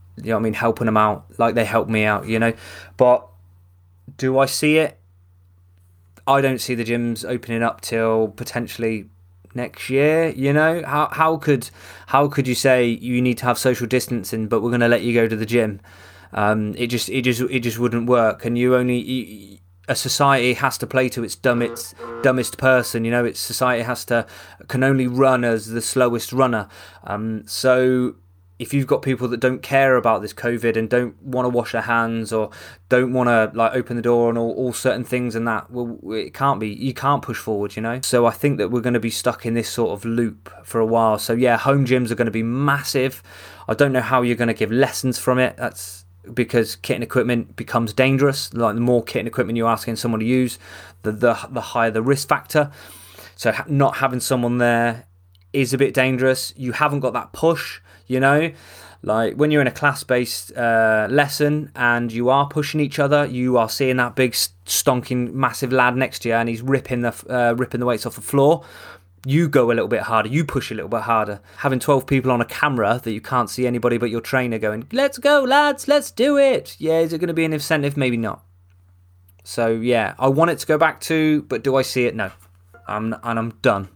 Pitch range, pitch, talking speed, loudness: 110-130 Hz, 120 Hz, 225 wpm, -20 LUFS